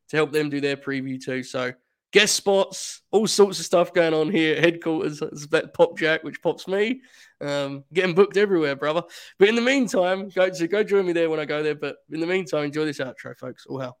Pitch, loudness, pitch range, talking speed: 165 Hz, -22 LUFS, 150-195 Hz, 235 wpm